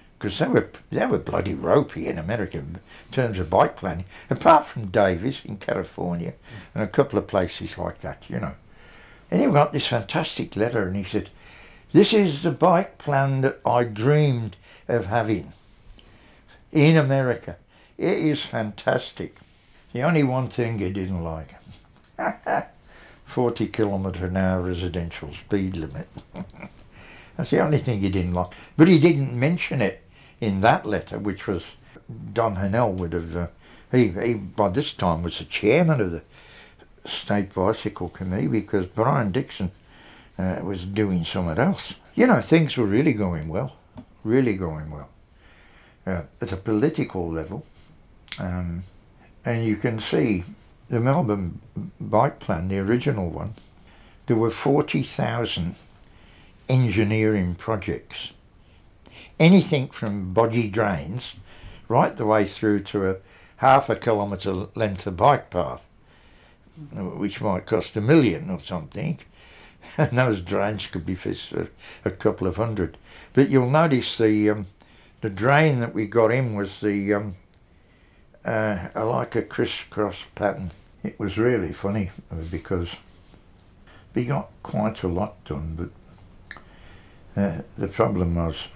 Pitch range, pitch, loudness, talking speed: 90-120 Hz, 105 Hz, -23 LUFS, 140 wpm